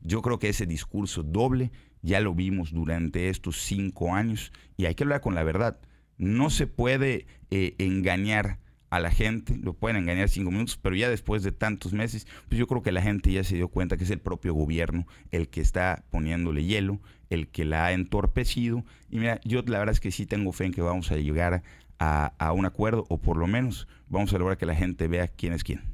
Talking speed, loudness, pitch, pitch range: 225 wpm, -28 LUFS, 95 Hz, 85-110 Hz